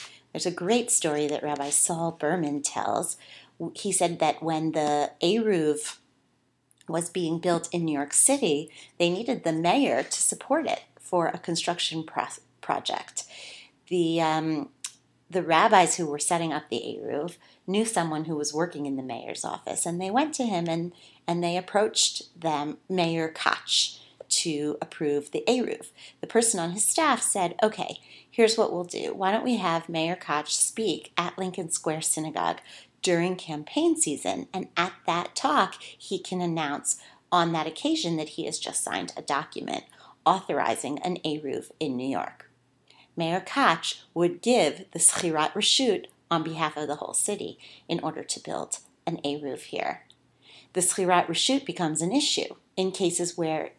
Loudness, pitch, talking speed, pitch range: -26 LUFS, 170 Hz, 165 wpm, 155-185 Hz